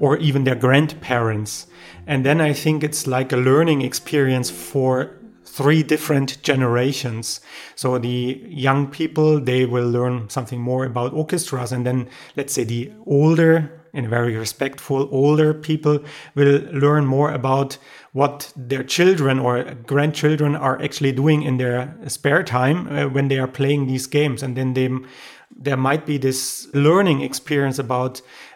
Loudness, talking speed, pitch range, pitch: -20 LUFS, 150 wpm, 130-150 Hz, 135 Hz